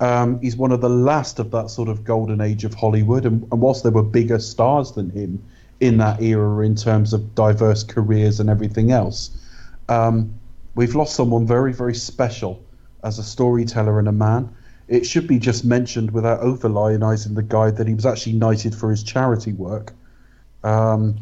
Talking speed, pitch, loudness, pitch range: 185 wpm, 115 Hz, -19 LUFS, 110-120 Hz